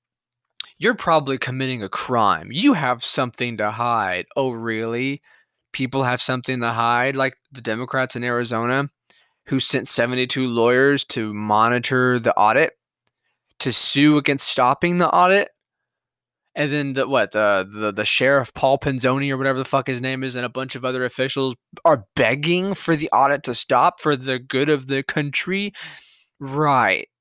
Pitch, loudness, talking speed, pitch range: 130 Hz, -19 LUFS, 160 wpm, 125-145 Hz